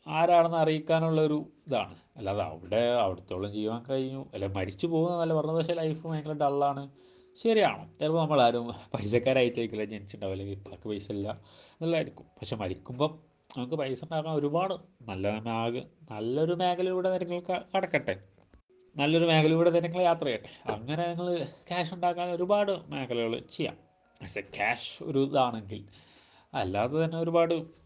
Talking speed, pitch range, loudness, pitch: 125 wpm, 115-170 Hz, -30 LUFS, 150 Hz